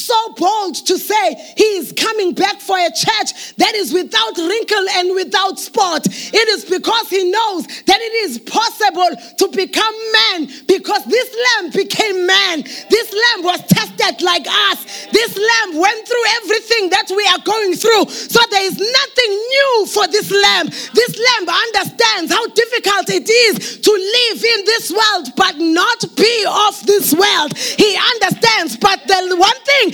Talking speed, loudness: 165 wpm, -13 LUFS